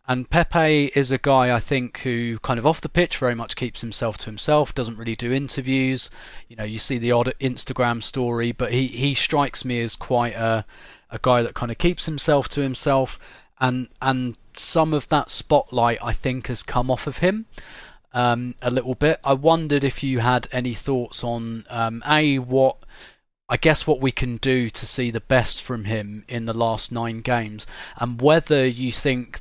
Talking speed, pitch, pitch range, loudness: 200 wpm, 125 Hz, 120-140 Hz, -22 LUFS